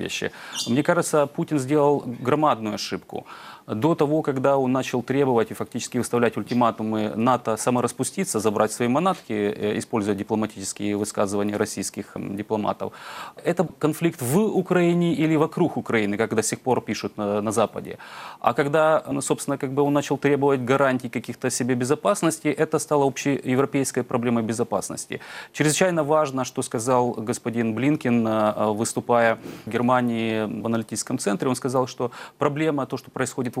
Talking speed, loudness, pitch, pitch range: 140 wpm, -23 LUFS, 125 Hz, 110-145 Hz